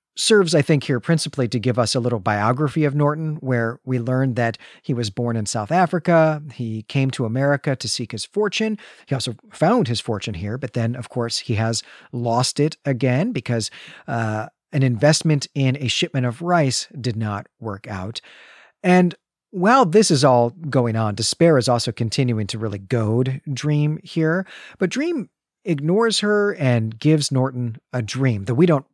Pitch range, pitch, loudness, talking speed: 120-155 Hz, 130 Hz, -20 LUFS, 180 wpm